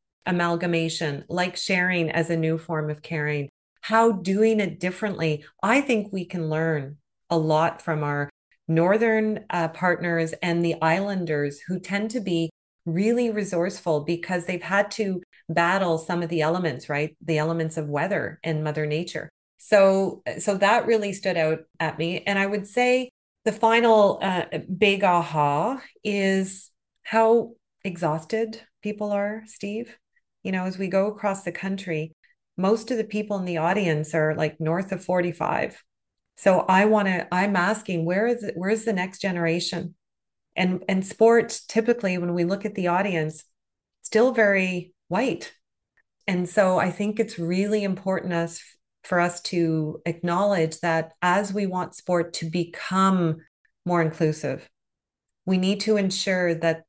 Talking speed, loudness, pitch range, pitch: 155 wpm, -24 LUFS, 165-205 Hz, 180 Hz